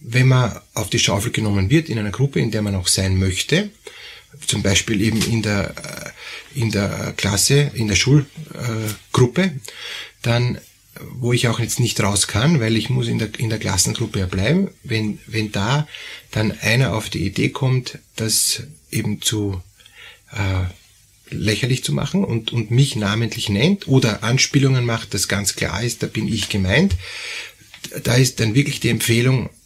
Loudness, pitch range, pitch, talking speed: -19 LUFS, 105-130 Hz, 115 Hz, 170 wpm